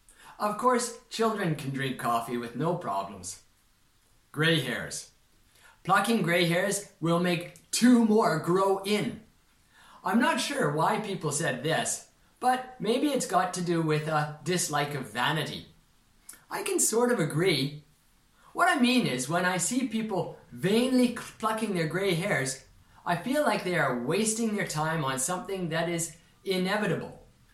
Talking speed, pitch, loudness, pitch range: 150 wpm, 180 Hz, -28 LUFS, 155-225 Hz